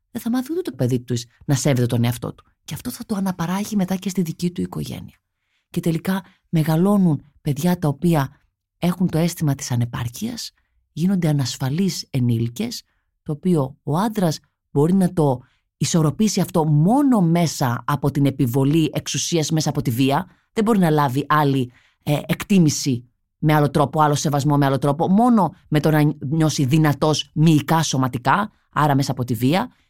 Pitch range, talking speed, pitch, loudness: 135-175 Hz, 170 wpm, 150 Hz, -20 LUFS